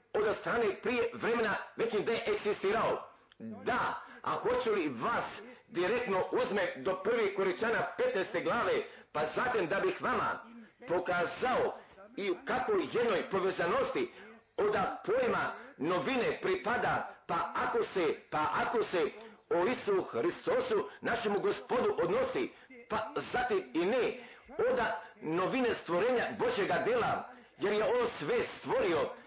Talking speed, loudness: 125 wpm, -33 LUFS